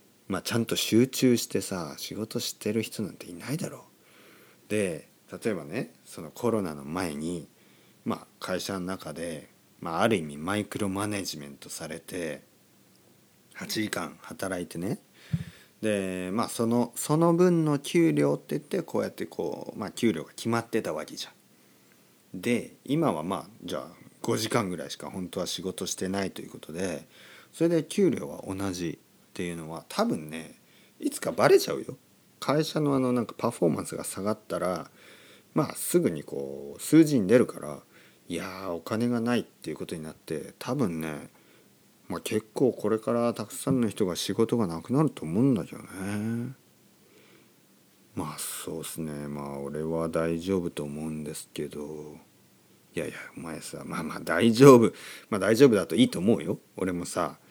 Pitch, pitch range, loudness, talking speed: 105 Hz, 80-120 Hz, -28 LUFS, 300 characters per minute